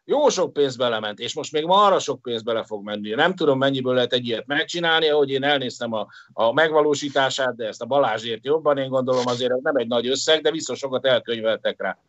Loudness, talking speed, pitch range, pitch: -21 LUFS, 225 wpm, 120-145 Hz, 130 Hz